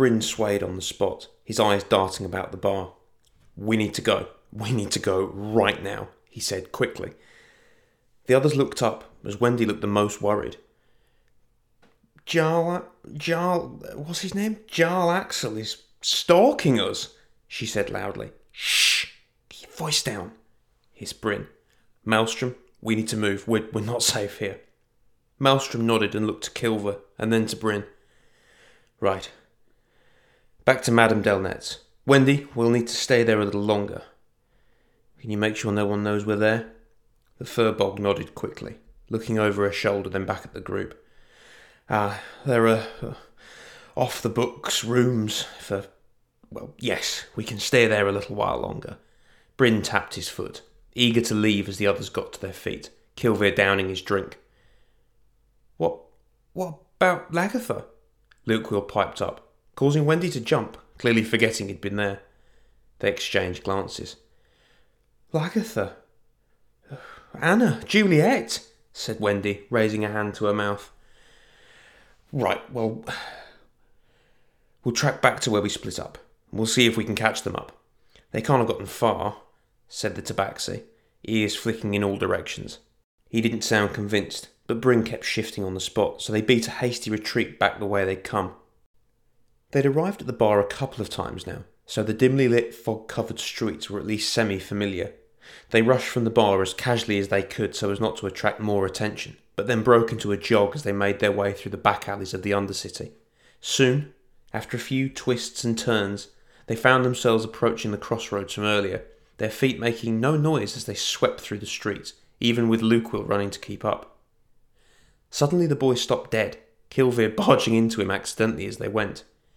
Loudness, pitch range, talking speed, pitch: -24 LUFS, 100-125 Hz, 165 wpm, 110 Hz